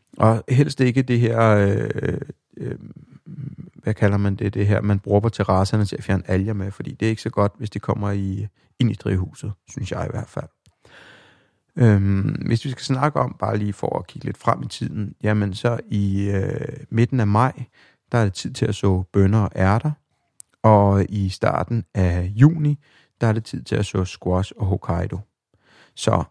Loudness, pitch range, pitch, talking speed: -21 LUFS, 100-125 Hz, 105 Hz, 200 wpm